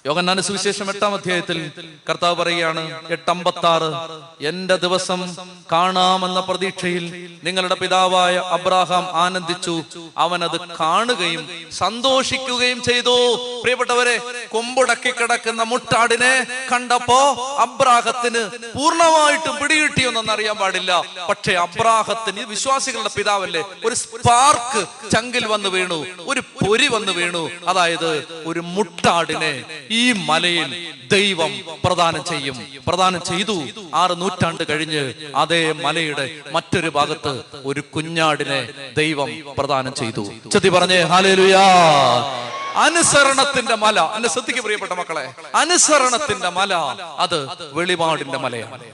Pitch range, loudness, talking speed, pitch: 165-225 Hz, -18 LUFS, 95 wpm, 180 Hz